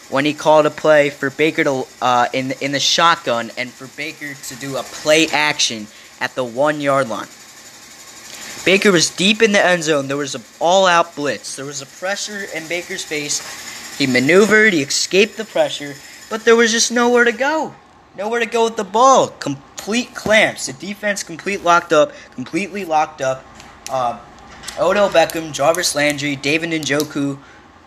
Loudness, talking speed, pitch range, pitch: -16 LUFS, 175 wpm, 140-200 Hz, 155 Hz